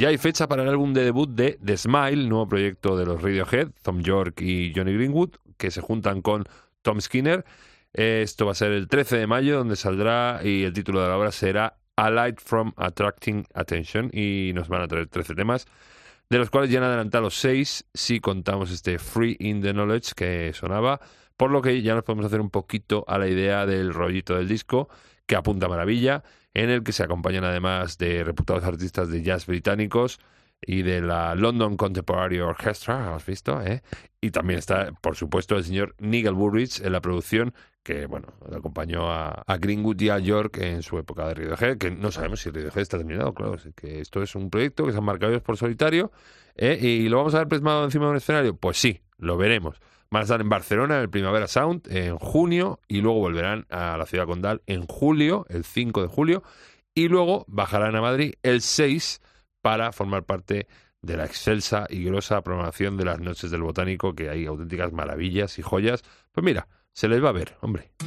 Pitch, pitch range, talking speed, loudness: 100 Hz, 90-115 Hz, 205 wpm, -24 LUFS